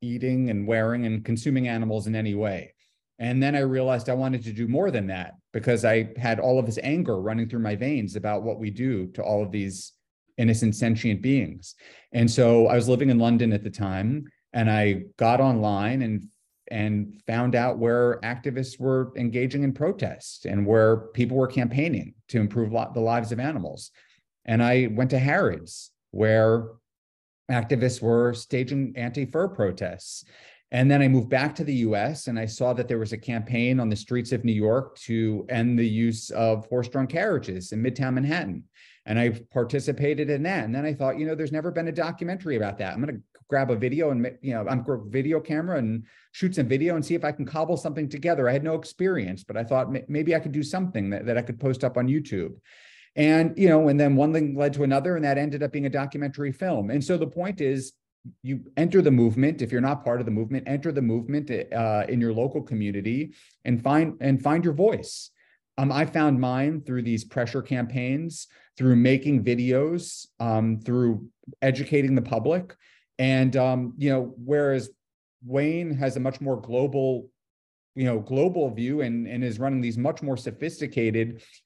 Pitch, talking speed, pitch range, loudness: 125 Hz, 200 wpm, 115-140 Hz, -25 LUFS